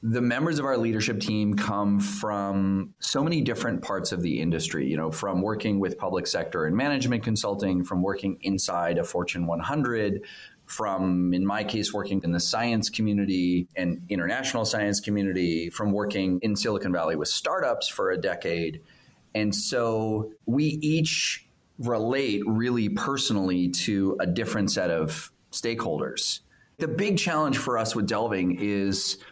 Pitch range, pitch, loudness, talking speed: 95-115 Hz, 105 Hz, -26 LUFS, 155 wpm